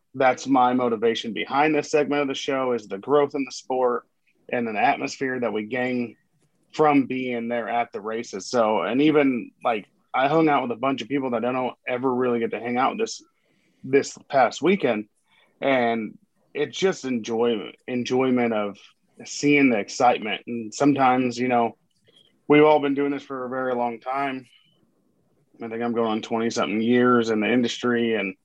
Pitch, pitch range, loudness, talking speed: 125 Hz, 120-140 Hz, -23 LUFS, 190 wpm